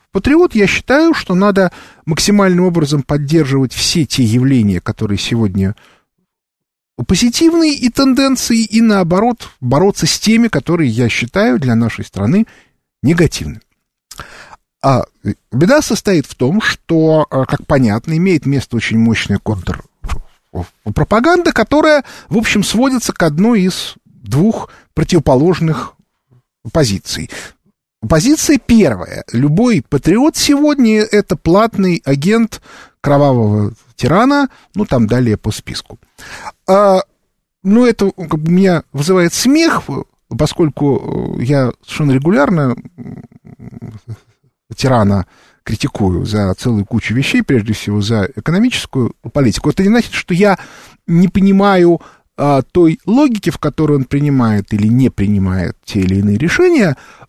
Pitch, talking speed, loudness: 160 Hz, 115 wpm, -13 LUFS